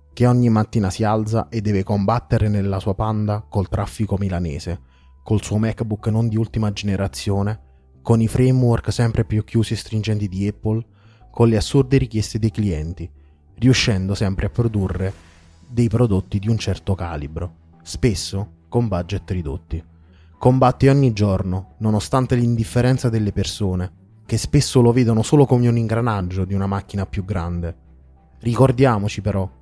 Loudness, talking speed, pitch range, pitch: -20 LUFS, 150 wpm, 95-115 Hz, 105 Hz